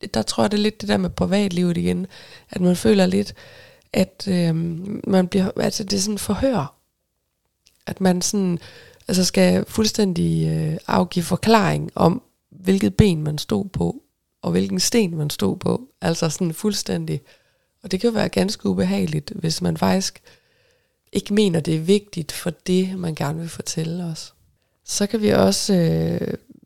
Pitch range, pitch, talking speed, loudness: 160-200 Hz, 180 Hz, 170 wpm, -21 LUFS